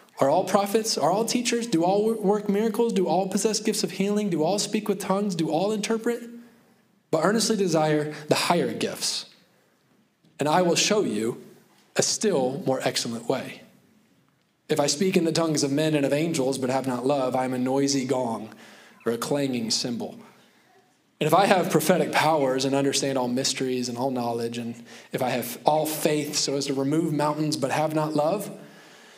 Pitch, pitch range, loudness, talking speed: 155 Hz, 135-200 Hz, -24 LUFS, 190 wpm